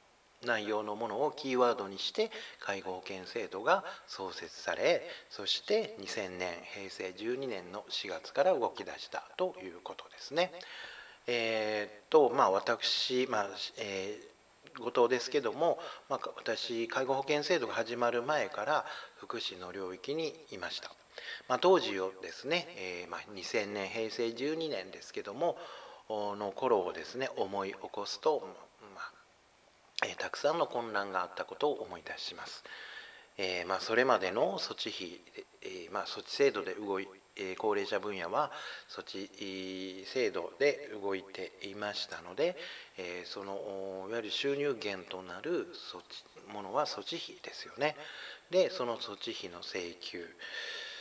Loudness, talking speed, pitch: -35 LUFS, 265 characters per minute, 145 Hz